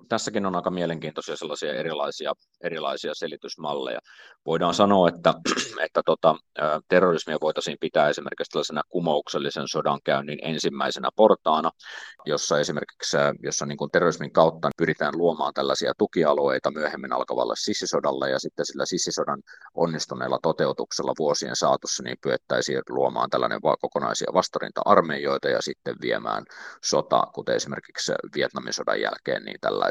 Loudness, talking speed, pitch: -25 LUFS, 125 wpm, 85 Hz